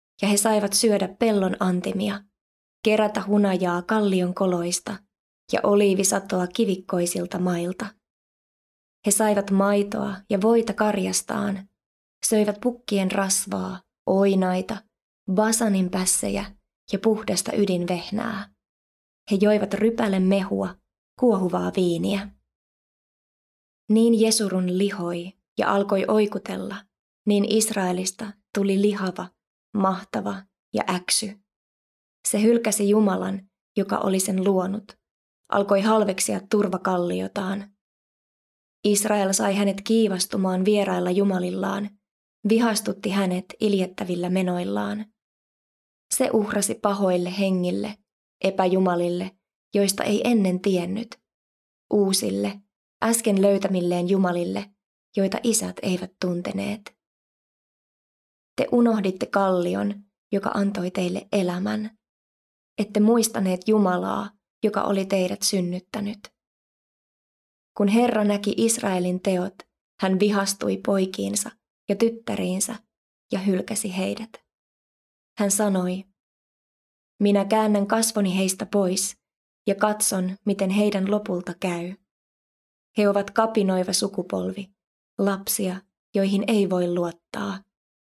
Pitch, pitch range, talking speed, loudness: 200 Hz, 185-210 Hz, 90 wpm, -23 LUFS